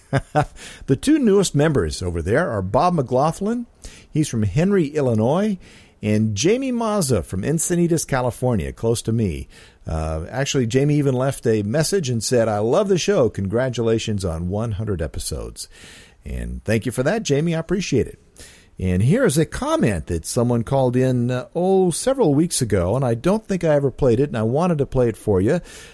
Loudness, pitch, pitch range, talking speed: -20 LUFS, 130 Hz, 105-165 Hz, 180 wpm